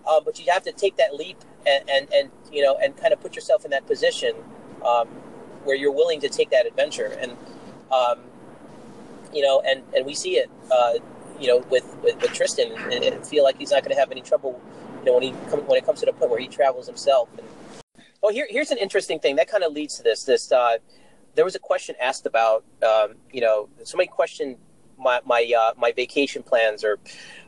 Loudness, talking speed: -22 LUFS, 225 wpm